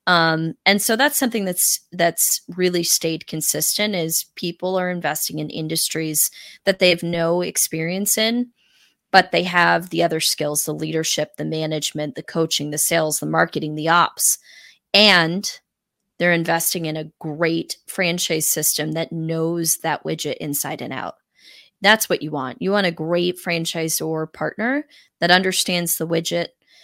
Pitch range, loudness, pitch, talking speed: 160-185 Hz, -19 LUFS, 170 Hz, 155 wpm